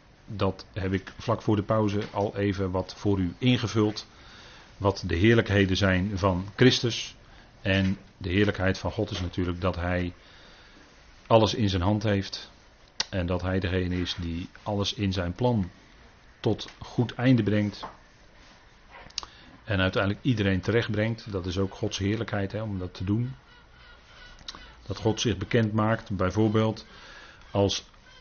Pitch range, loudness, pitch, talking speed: 95-110 Hz, -27 LUFS, 100 Hz, 145 wpm